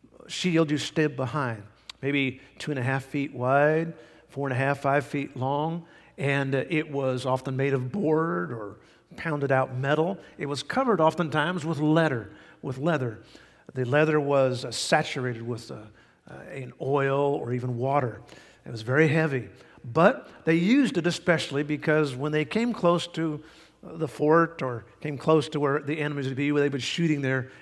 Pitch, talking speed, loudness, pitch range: 145 Hz, 180 wpm, -26 LUFS, 135-160 Hz